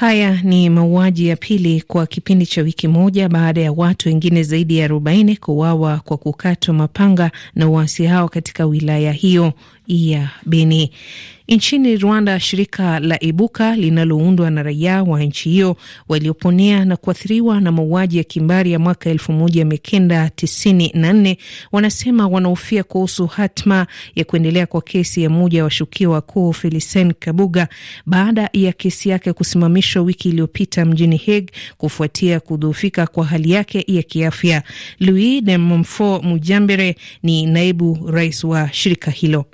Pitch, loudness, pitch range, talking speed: 170 Hz, -15 LUFS, 160-190 Hz, 135 wpm